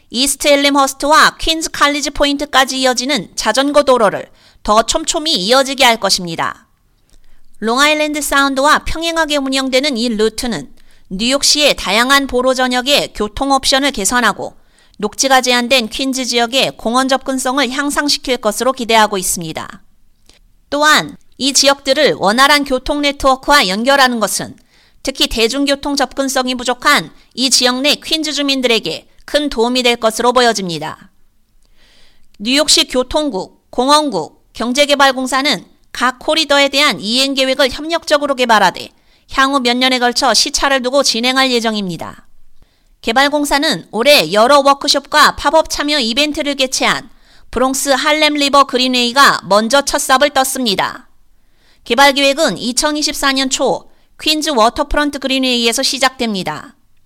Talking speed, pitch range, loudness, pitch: 320 characters per minute, 245-290 Hz, -12 LUFS, 270 Hz